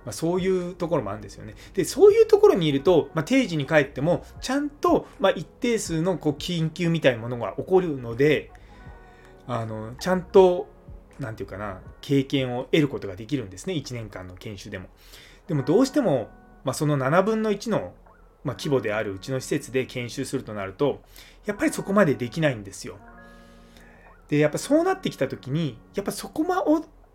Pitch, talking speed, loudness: 140 Hz, 385 characters per minute, -24 LUFS